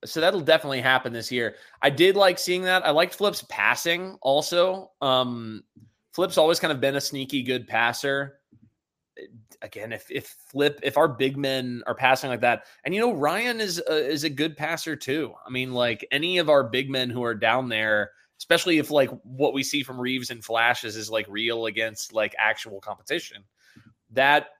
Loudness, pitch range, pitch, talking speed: -24 LUFS, 120-160 Hz, 135 Hz, 195 wpm